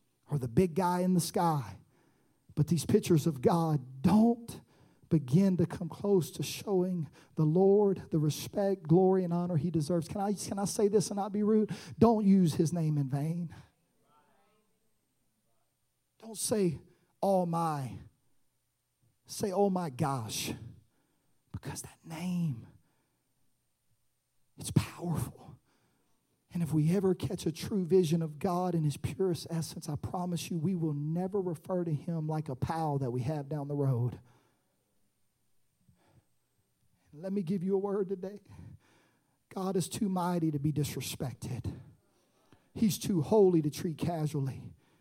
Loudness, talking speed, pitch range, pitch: -31 LUFS, 145 wpm, 150-190 Hz, 170 Hz